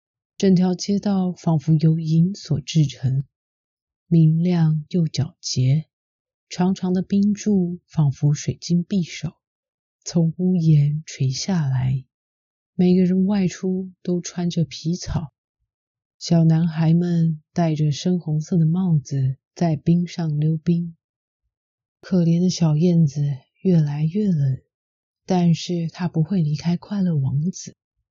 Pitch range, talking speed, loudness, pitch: 150-180 Hz, 175 characters per minute, -21 LUFS, 165 Hz